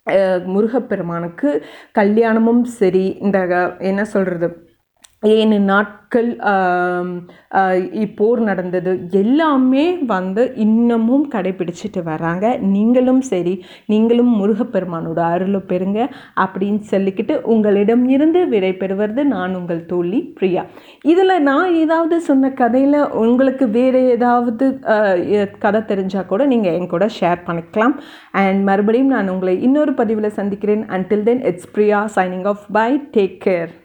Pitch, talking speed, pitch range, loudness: 210 Hz, 110 wpm, 185-240 Hz, -16 LUFS